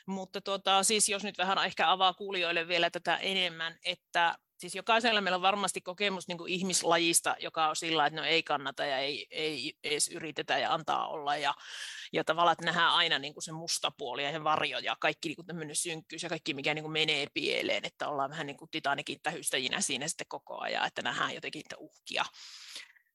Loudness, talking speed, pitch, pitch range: -31 LUFS, 200 wpm, 170 Hz, 155-190 Hz